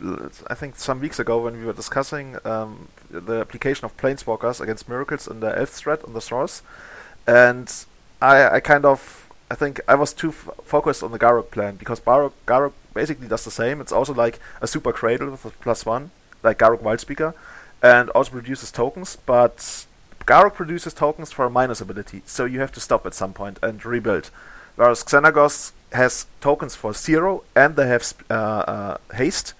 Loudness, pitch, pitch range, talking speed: -20 LUFS, 125 Hz, 115-145 Hz, 190 wpm